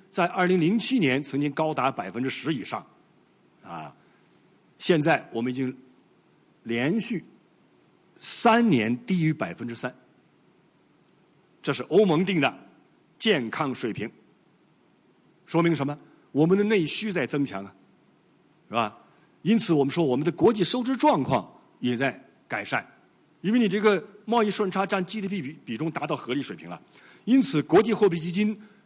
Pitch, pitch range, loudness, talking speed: 175 Hz, 140-210 Hz, -25 LUFS, 220 characters per minute